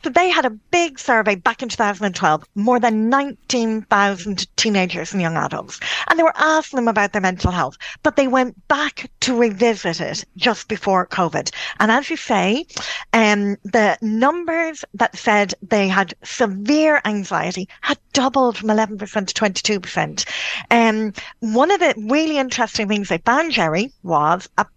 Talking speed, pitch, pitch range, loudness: 160 wpm, 225 Hz, 200-265 Hz, -18 LUFS